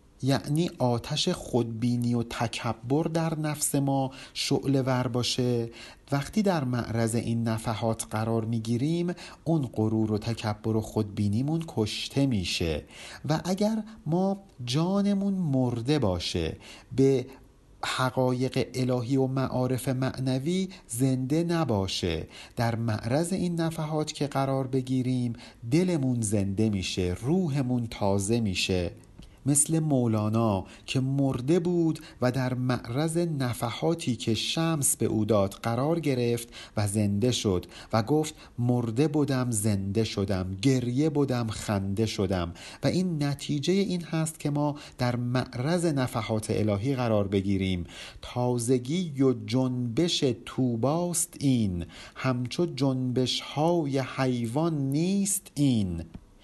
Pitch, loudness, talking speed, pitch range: 125 Hz, -28 LUFS, 110 wpm, 115-150 Hz